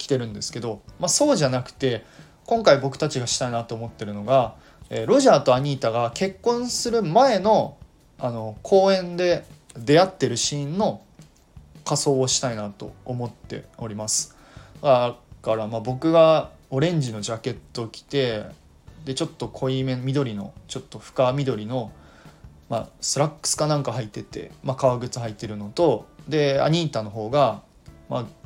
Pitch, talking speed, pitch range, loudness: 130 Hz, 315 characters per minute, 115-150 Hz, -23 LUFS